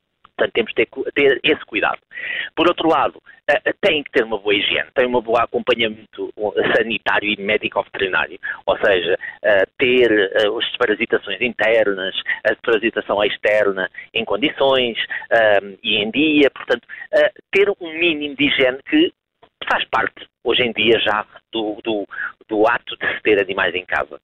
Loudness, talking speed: -18 LUFS, 150 wpm